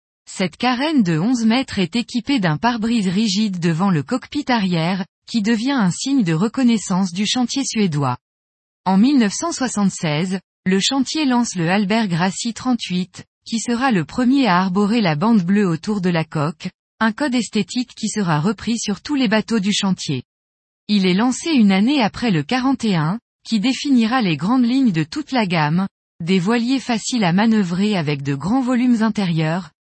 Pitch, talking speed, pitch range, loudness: 210 Hz, 170 wpm, 180-245 Hz, -18 LUFS